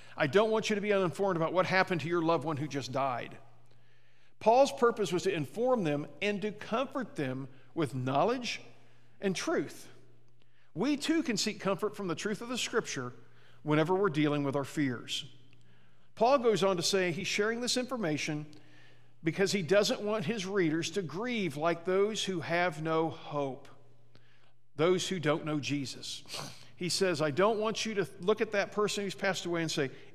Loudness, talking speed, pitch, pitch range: -31 LUFS, 185 wpm, 175 Hz, 140-205 Hz